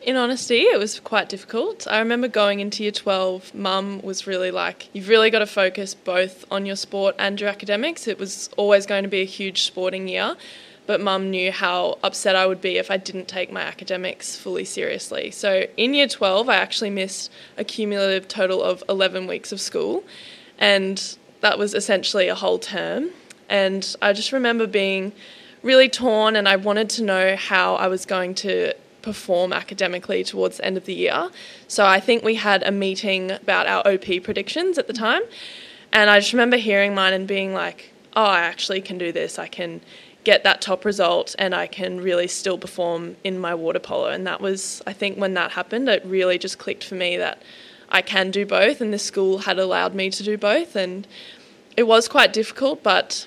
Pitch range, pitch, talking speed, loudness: 190-215 Hz, 195 Hz, 205 wpm, -21 LUFS